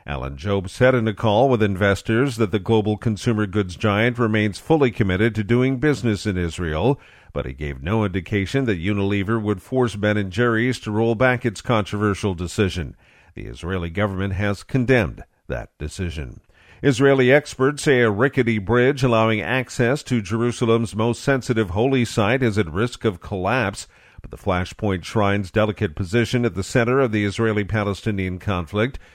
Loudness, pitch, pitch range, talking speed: -21 LUFS, 110 Hz, 100-120 Hz, 165 wpm